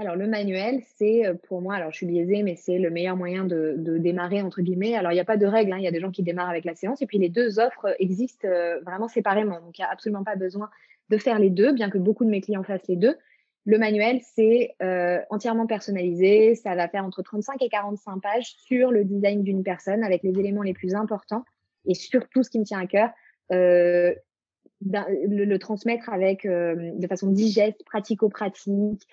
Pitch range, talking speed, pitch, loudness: 185-220 Hz, 225 wpm, 200 Hz, -24 LUFS